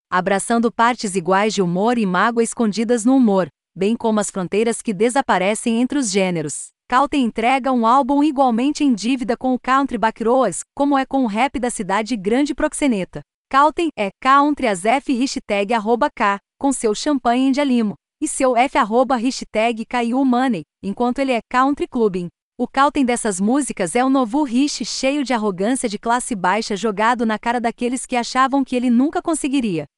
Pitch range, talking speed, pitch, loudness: 220-270 Hz, 175 wpm, 245 Hz, -18 LUFS